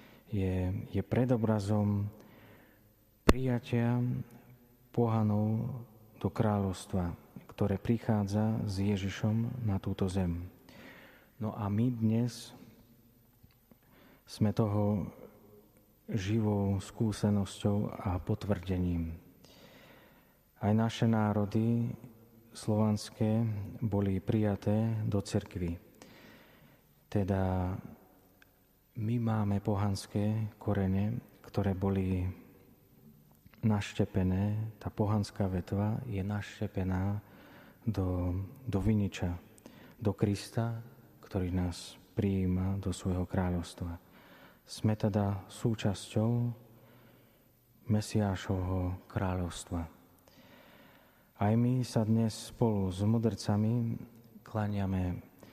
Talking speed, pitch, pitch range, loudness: 75 wpm, 105 Hz, 95-115 Hz, -33 LUFS